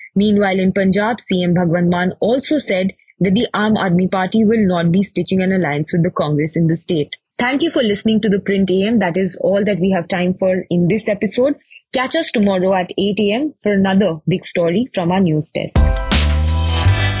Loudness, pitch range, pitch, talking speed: -16 LUFS, 175-210 Hz, 190 Hz, 200 wpm